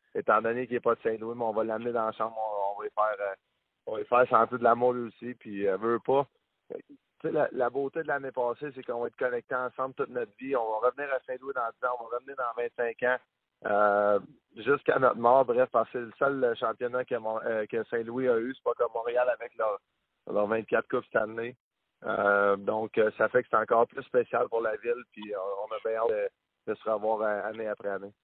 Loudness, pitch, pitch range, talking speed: -29 LUFS, 120 Hz, 110-140 Hz, 240 wpm